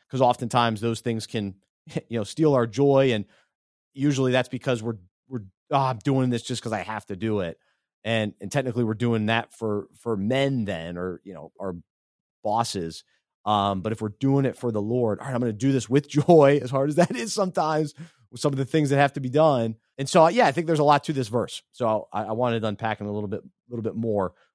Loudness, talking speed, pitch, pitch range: -24 LUFS, 245 wpm, 120 Hz, 110-135 Hz